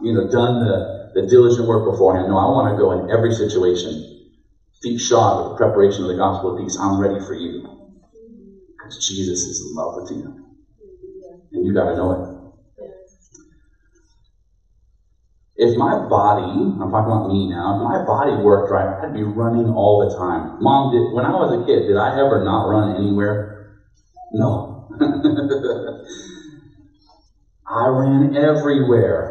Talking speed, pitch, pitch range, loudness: 160 wpm, 110 Hz, 95-145 Hz, -18 LUFS